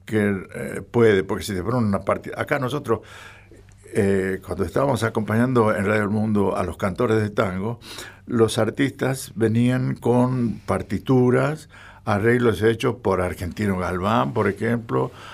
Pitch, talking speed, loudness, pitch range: 110 Hz, 140 wpm, -22 LUFS, 100-120 Hz